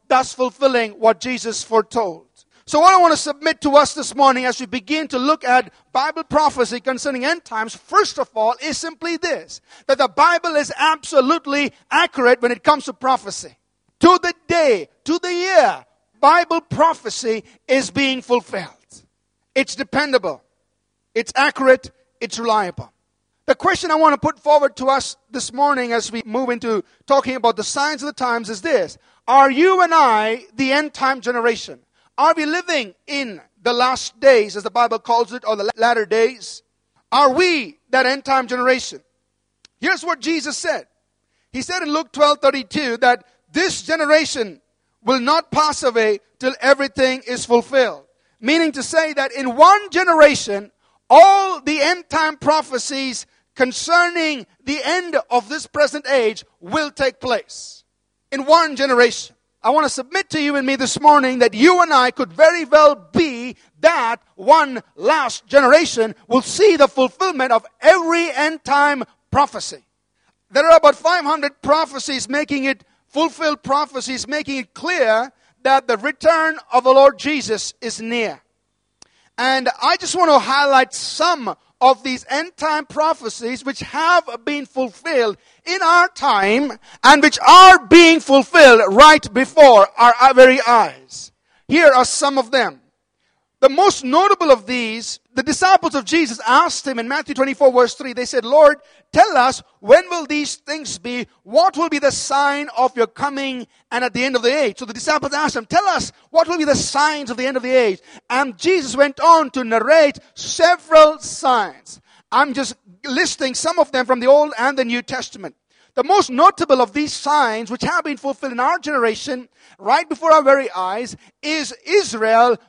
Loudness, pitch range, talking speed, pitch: -16 LUFS, 250-310 Hz, 170 wpm, 275 Hz